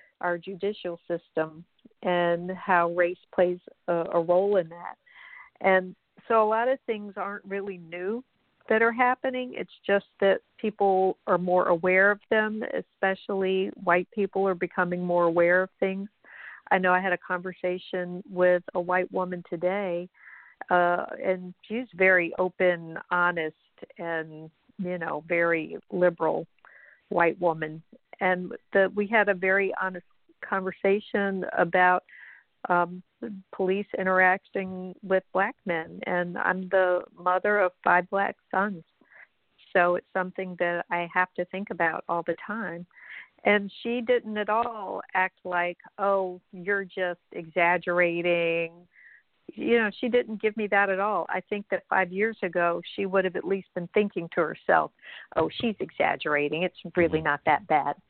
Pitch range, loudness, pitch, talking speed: 175-200 Hz, -26 LUFS, 185 Hz, 150 wpm